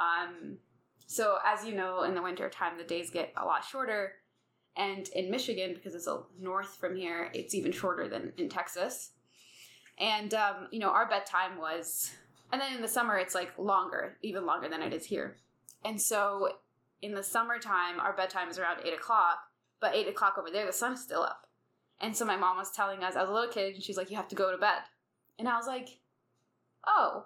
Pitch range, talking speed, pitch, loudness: 180-210 Hz, 215 wpm, 195 Hz, -33 LUFS